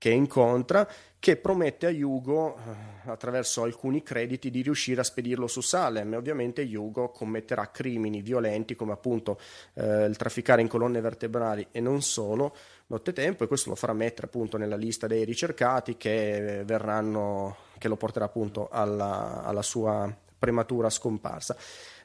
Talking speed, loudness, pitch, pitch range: 145 wpm, -29 LUFS, 115 Hz, 105-125 Hz